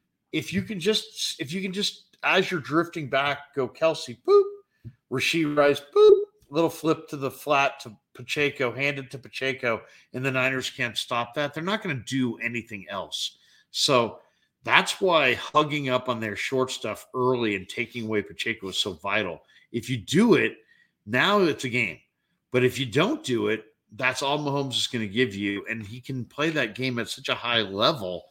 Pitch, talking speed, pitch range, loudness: 130 Hz, 195 wpm, 120-155 Hz, -25 LUFS